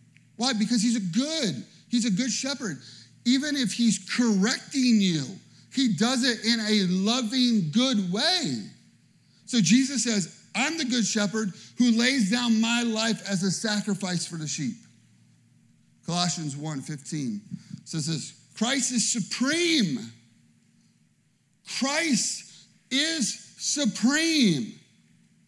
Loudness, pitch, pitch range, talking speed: -25 LUFS, 220 Hz, 185-245 Hz, 120 wpm